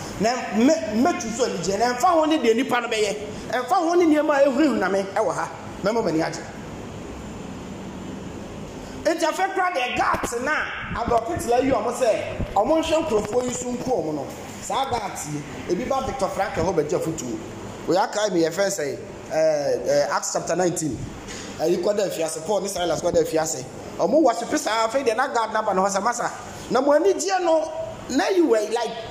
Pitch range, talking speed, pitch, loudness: 195-310 Hz, 165 wpm, 240 Hz, -22 LUFS